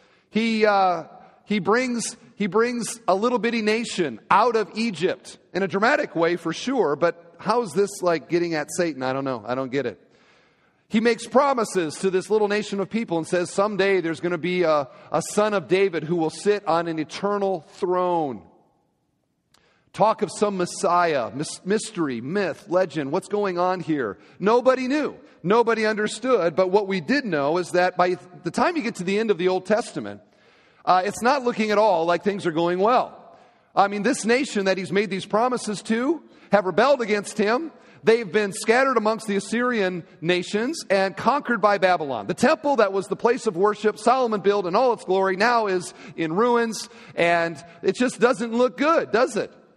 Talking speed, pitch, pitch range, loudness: 190 wpm, 200 Hz, 180-230 Hz, -22 LUFS